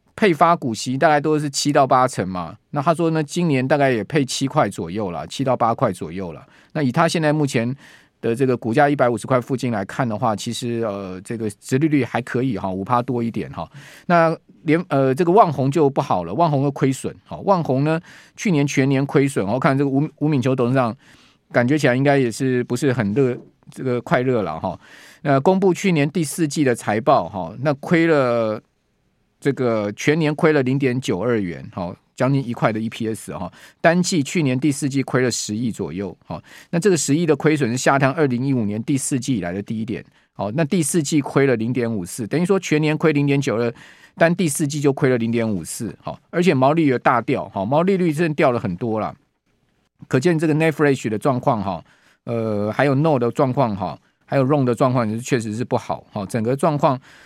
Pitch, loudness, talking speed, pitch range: 135 Hz, -20 LUFS, 325 characters per minute, 120-155 Hz